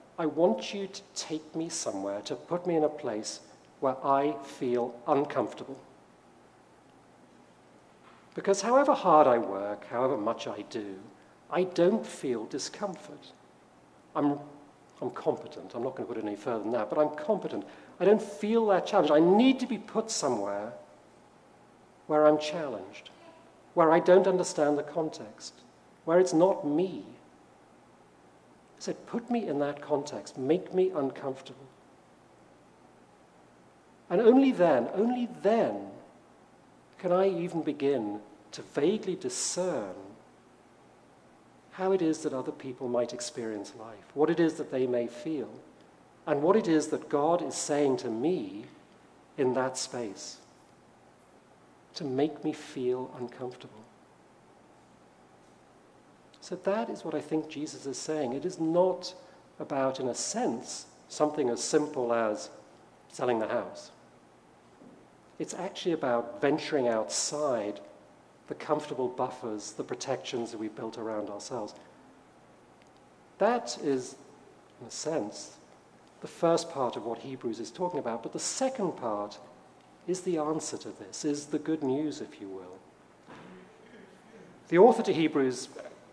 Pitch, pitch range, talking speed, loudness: 150 Hz, 125-180 Hz, 140 wpm, -30 LUFS